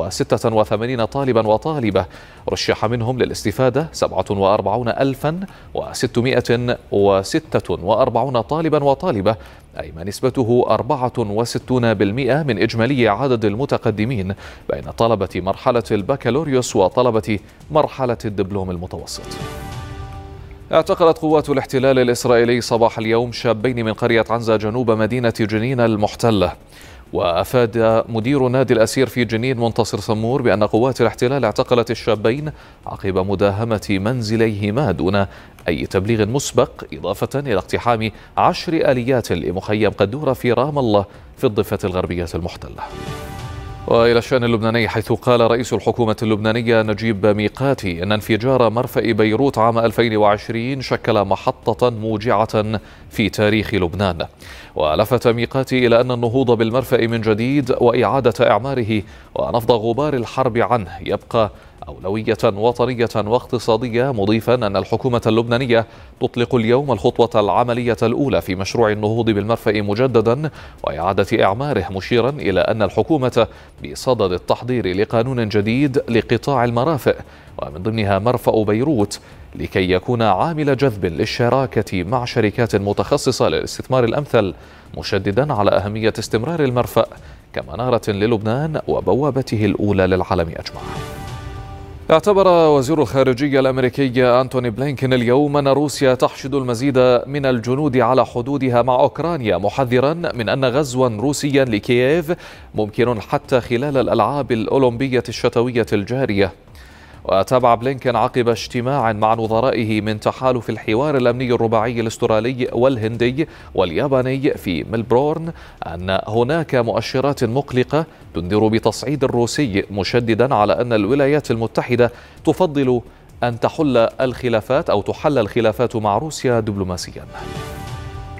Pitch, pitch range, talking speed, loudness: 115 Hz, 105-130 Hz, 110 wpm, -18 LUFS